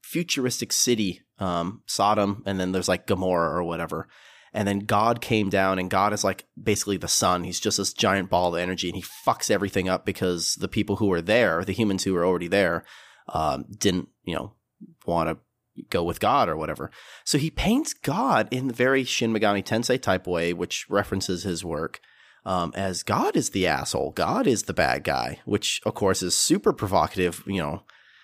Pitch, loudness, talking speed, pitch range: 100 Hz, -25 LUFS, 200 wpm, 90-110 Hz